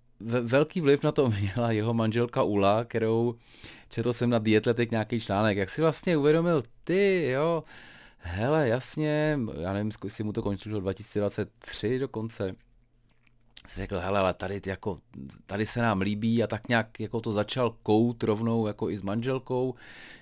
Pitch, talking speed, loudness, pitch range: 115 Hz, 155 wpm, -28 LUFS, 105-125 Hz